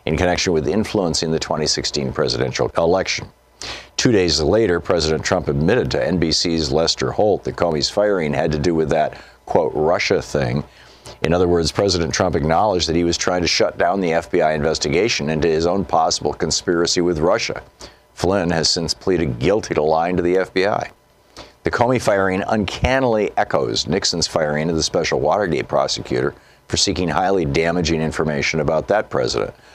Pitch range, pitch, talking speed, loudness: 80-90 Hz, 85 Hz, 165 wpm, -18 LUFS